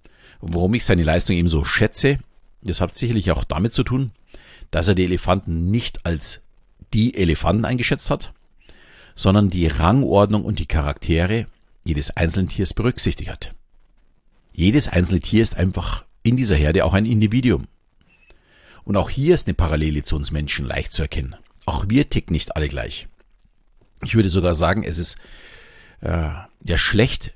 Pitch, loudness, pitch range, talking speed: 90 Hz, -20 LUFS, 80-110 Hz, 160 wpm